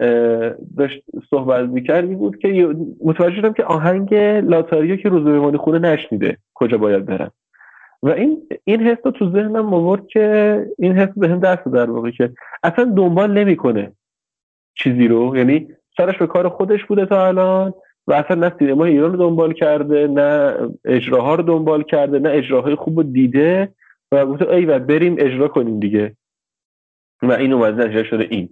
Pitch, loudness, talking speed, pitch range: 160 Hz, -16 LUFS, 165 wpm, 130-190 Hz